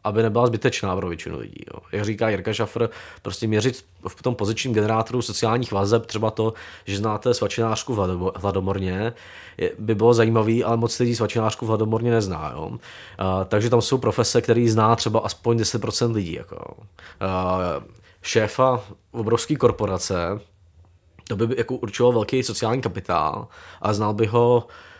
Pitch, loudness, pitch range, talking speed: 110 Hz, -22 LUFS, 100-115 Hz, 155 wpm